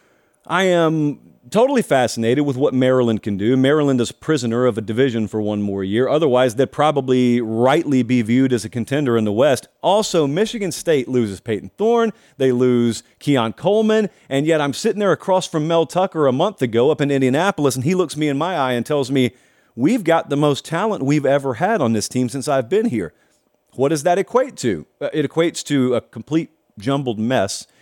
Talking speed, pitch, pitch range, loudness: 205 wpm, 140 Hz, 125-165 Hz, -18 LUFS